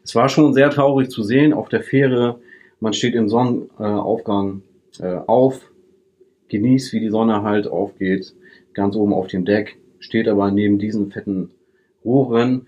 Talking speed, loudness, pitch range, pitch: 150 wpm, -18 LUFS, 100-130 Hz, 110 Hz